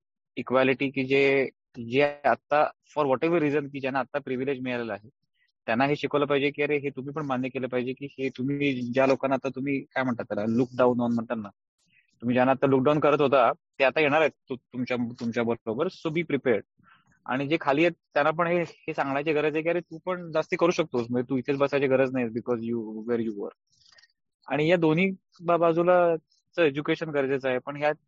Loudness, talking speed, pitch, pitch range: -26 LUFS, 195 wpm, 140 Hz, 125-155 Hz